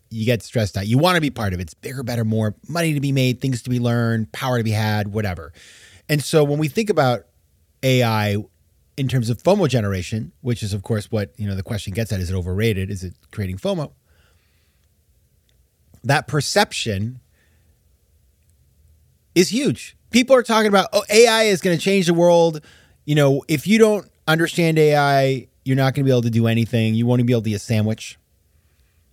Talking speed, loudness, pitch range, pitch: 205 wpm, -19 LUFS, 95-145 Hz, 115 Hz